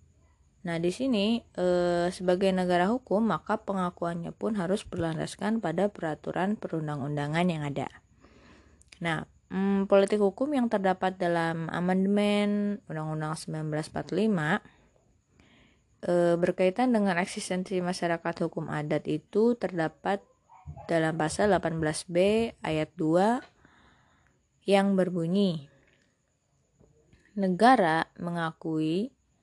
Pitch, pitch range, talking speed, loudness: 180 Hz, 165-200 Hz, 85 wpm, -28 LUFS